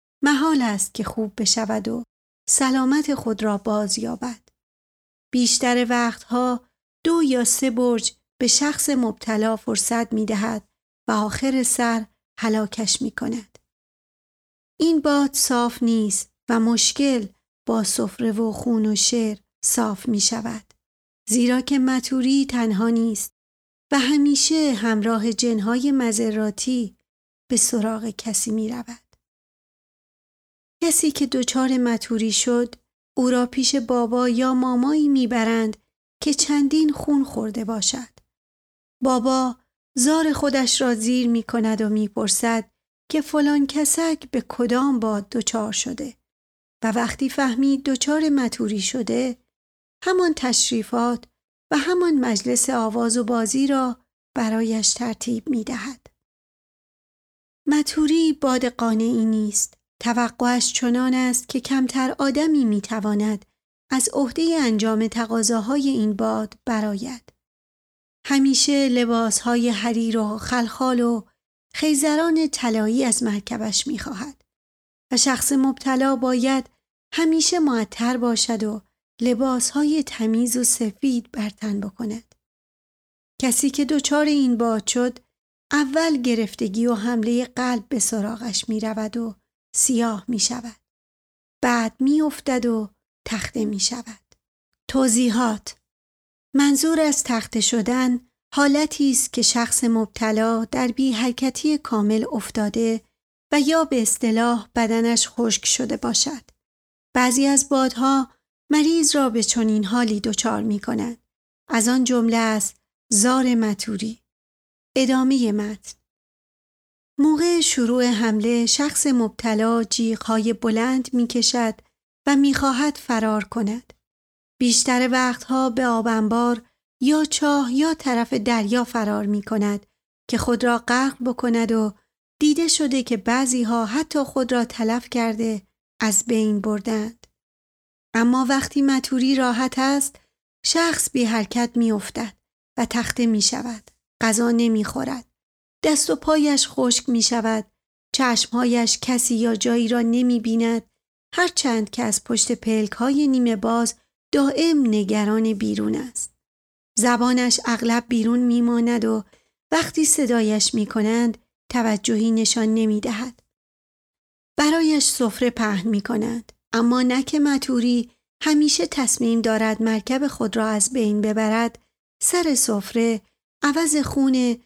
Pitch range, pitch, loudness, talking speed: 225-265 Hz, 240 Hz, -21 LUFS, 120 wpm